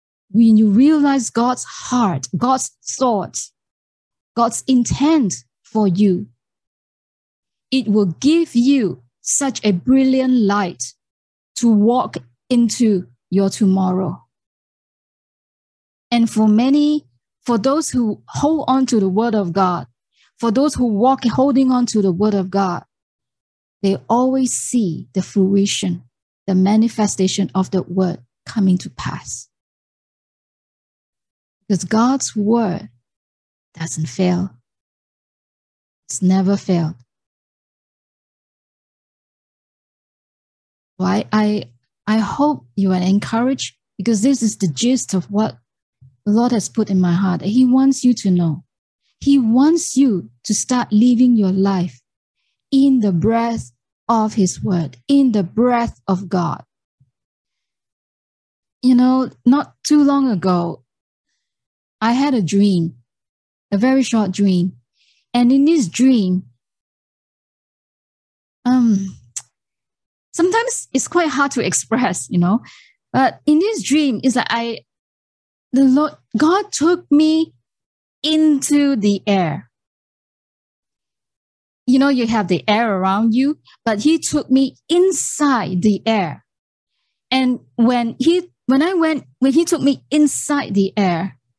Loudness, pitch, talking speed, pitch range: -17 LUFS, 220 Hz, 120 wpm, 185-260 Hz